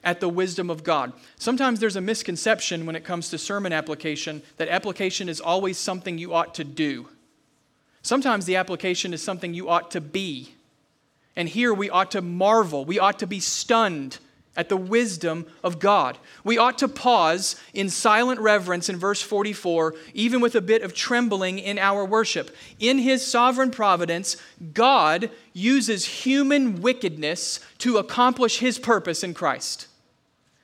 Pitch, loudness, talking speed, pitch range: 195 Hz, -23 LUFS, 160 wpm, 170-225 Hz